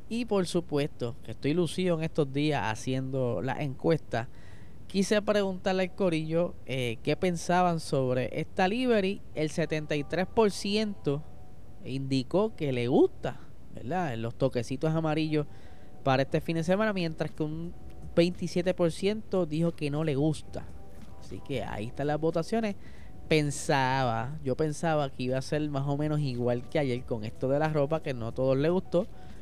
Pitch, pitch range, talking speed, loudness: 155 Hz, 130-175 Hz, 155 wpm, -30 LUFS